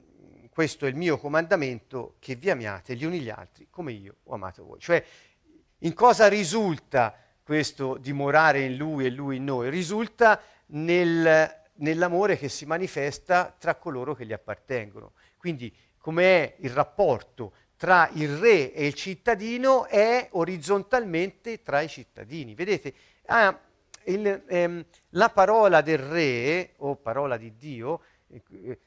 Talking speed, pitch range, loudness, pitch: 140 wpm, 135-185 Hz, -24 LUFS, 160 Hz